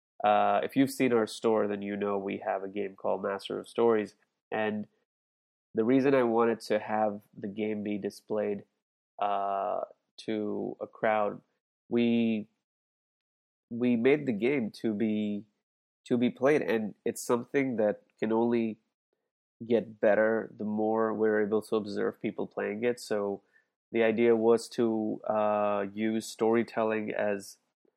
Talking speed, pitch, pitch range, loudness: 145 wpm, 110 Hz, 105-115 Hz, -30 LUFS